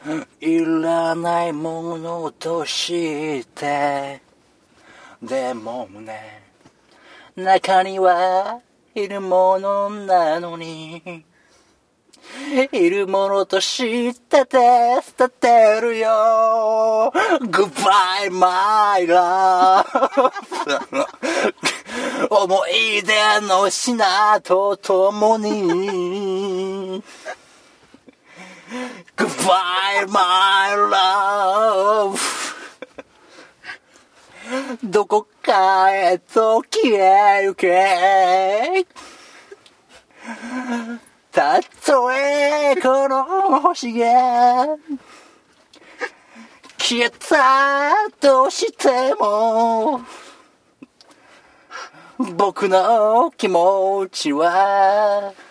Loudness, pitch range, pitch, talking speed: -17 LUFS, 185-255 Hz, 210 Hz, 105 characters per minute